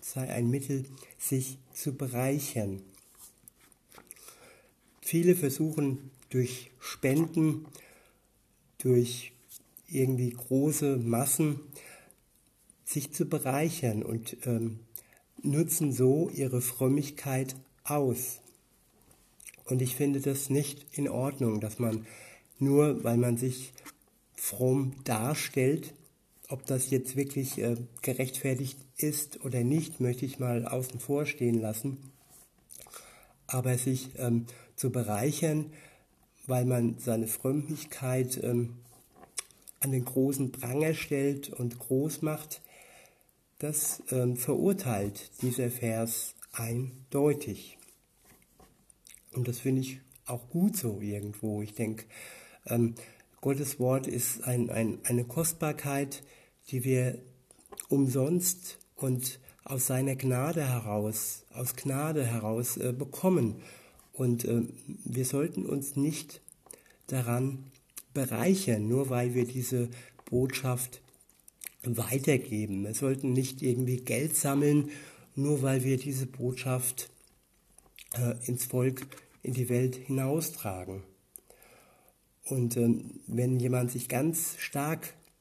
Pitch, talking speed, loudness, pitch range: 130 Hz, 105 wpm, -31 LUFS, 120-140 Hz